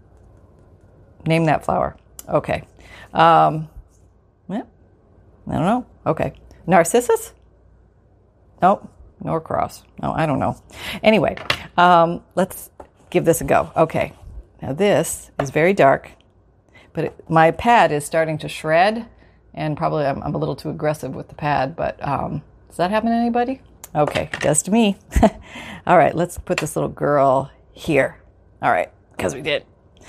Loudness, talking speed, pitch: -19 LUFS, 150 wpm, 160 Hz